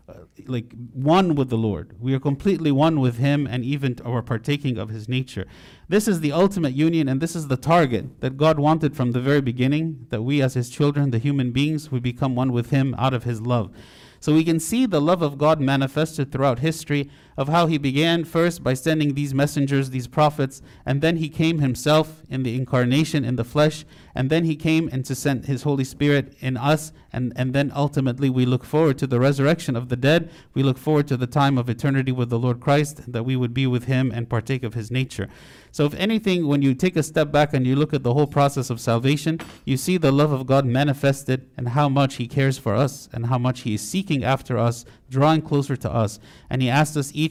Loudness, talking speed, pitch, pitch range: -22 LUFS, 230 wpm, 140 Hz, 125-150 Hz